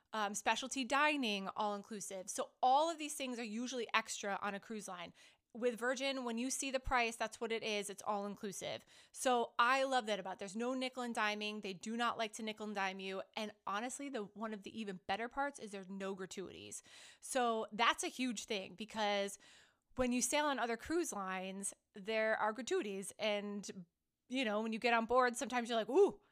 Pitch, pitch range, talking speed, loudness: 225 Hz, 205-255 Hz, 210 wpm, -38 LUFS